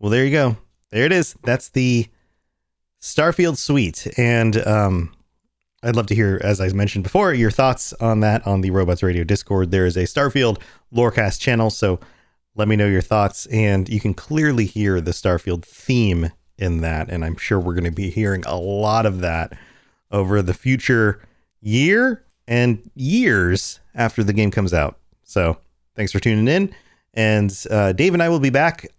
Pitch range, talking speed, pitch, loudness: 95-120 Hz, 180 wpm, 105 Hz, -19 LUFS